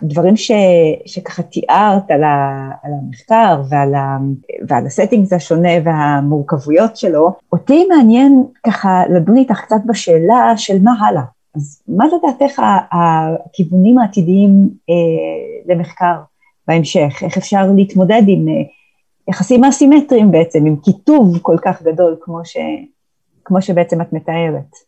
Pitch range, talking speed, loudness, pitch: 165-220 Hz, 125 wpm, -12 LUFS, 180 Hz